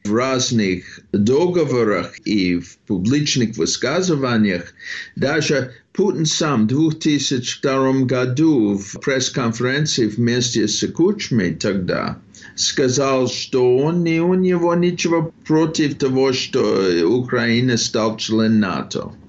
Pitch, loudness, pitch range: 130 Hz, -18 LUFS, 115-155 Hz